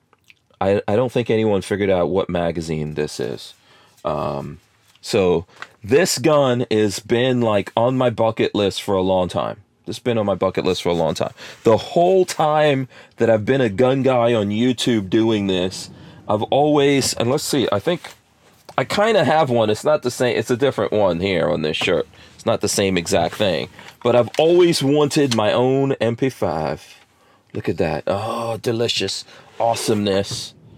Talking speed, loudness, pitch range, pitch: 180 wpm, -19 LUFS, 105-130 Hz, 115 Hz